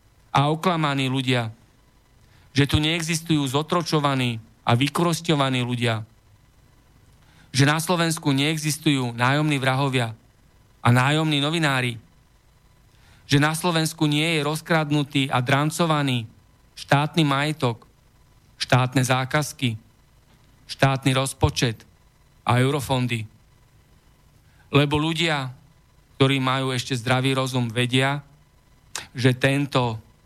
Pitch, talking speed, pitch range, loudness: 135 Hz, 90 wpm, 125-150 Hz, -22 LUFS